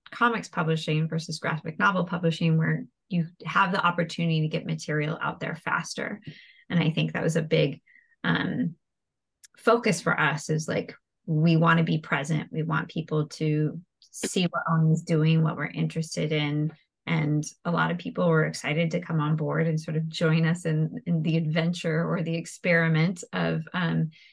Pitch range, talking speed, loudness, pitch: 155-170 Hz, 180 wpm, -26 LUFS, 165 Hz